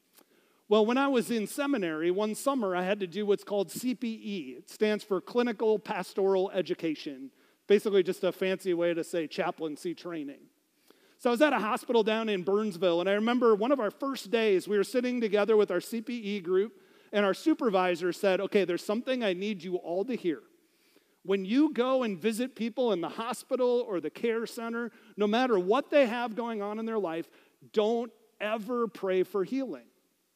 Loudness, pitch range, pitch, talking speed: -29 LUFS, 190-245 Hz, 215 Hz, 190 wpm